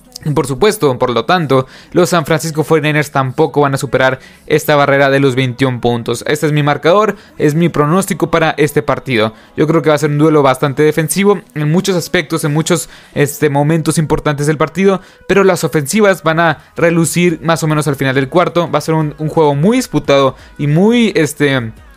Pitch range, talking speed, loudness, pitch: 145-170 Hz, 200 wpm, -13 LUFS, 155 Hz